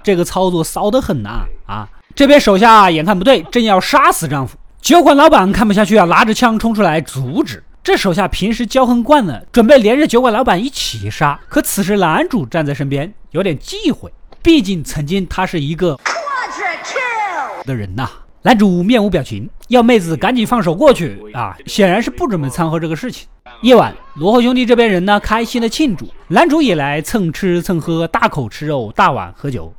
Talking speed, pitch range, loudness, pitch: 290 characters per minute, 155-245 Hz, -13 LUFS, 200 Hz